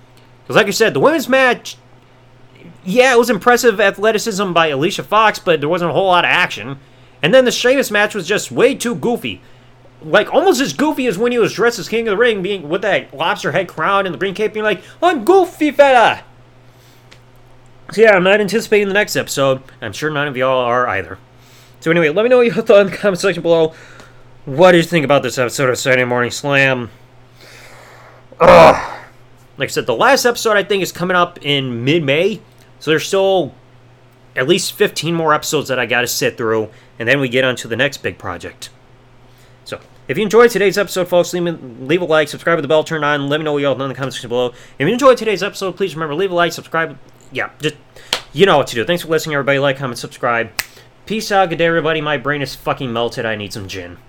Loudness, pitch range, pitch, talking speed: -15 LUFS, 125-200 Hz, 150 Hz, 235 wpm